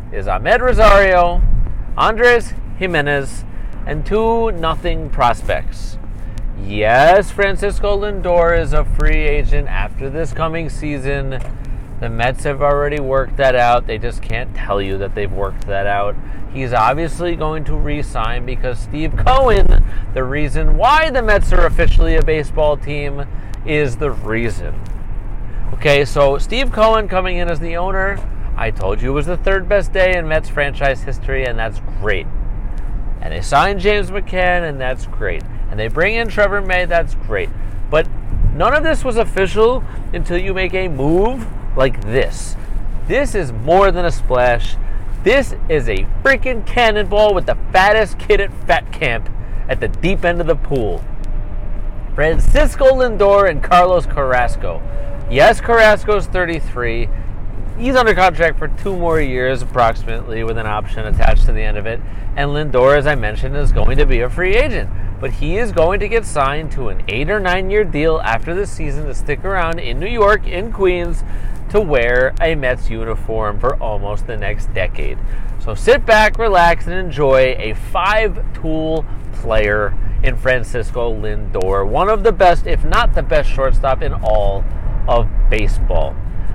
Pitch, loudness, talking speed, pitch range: 135 Hz, -16 LUFS, 165 wpm, 105-175 Hz